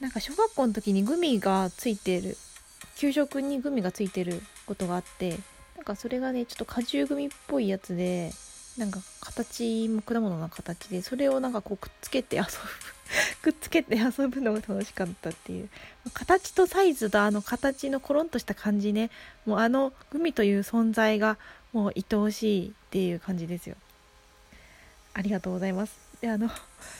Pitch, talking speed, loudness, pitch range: 215 Hz, 345 characters per minute, -29 LUFS, 190-260 Hz